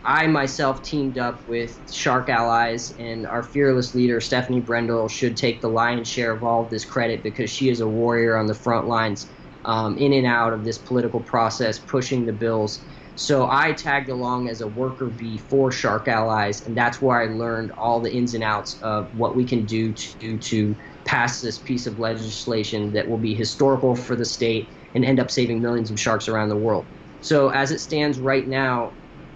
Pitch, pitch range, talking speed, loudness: 120 Hz, 110-130 Hz, 205 wpm, -22 LUFS